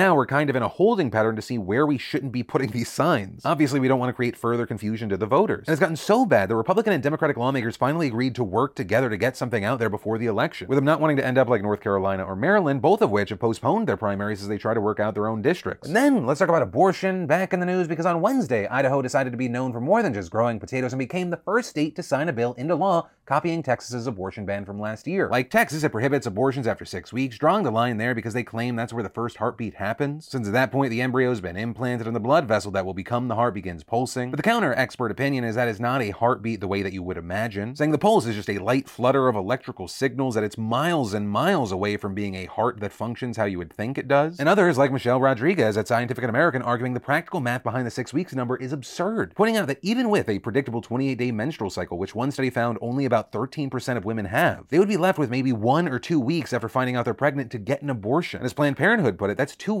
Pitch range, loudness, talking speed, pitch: 110-145 Hz, -24 LUFS, 280 wpm, 125 Hz